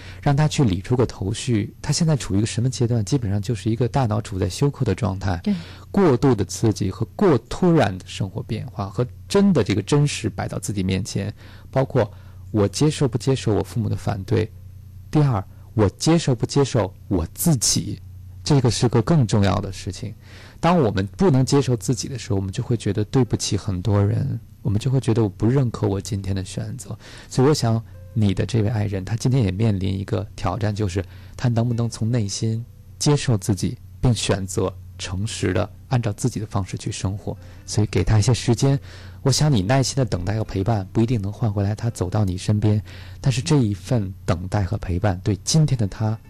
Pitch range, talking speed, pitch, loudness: 95-125 Hz, 300 characters per minute, 105 Hz, -22 LUFS